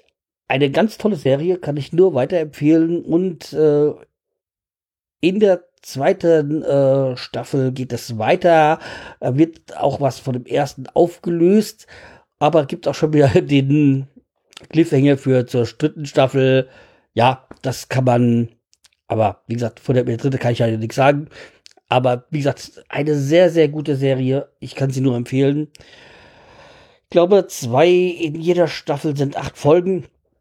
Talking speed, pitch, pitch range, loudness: 145 wpm, 145 Hz, 130-165 Hz, -18 LUFS